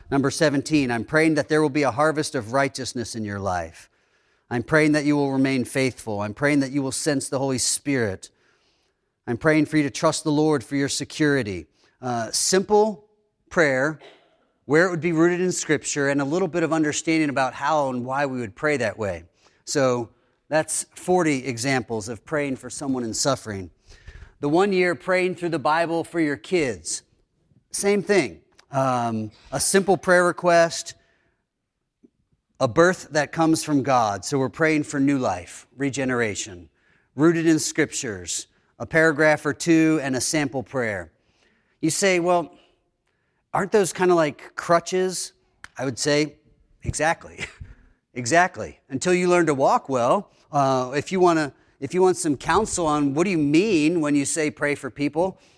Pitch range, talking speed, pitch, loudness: 130-165 Hz, 170 wpm, 145 Hz, -22 LUFS